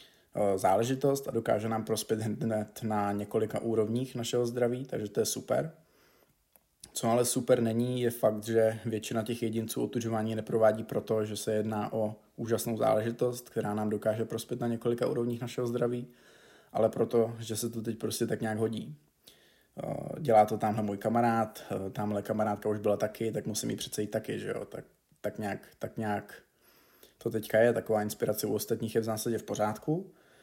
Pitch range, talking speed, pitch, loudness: 110-120 Hz, 175 wpm, 110 Hz, -31 LUFS